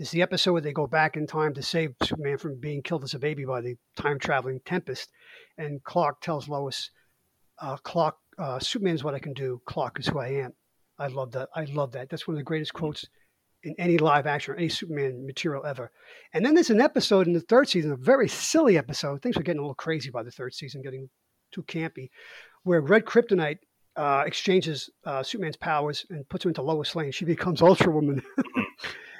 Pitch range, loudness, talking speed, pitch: 140-175 Hz, -26 LUFS, 220 wpm, 150 Hz